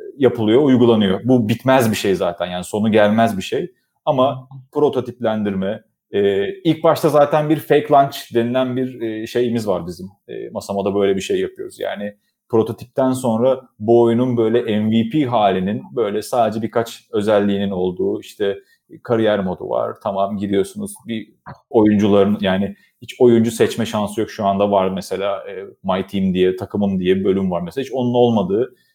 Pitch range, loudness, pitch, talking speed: 100-130 Hz, -18 LUFS, 115 Hz, 150 wpm